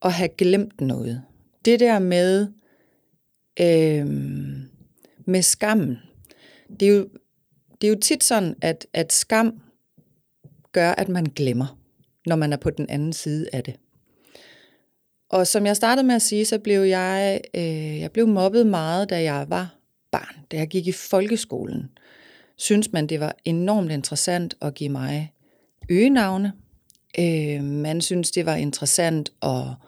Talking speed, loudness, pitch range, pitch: 150 wpm, -22 LUFS, 145-200 Hz, 170 Hz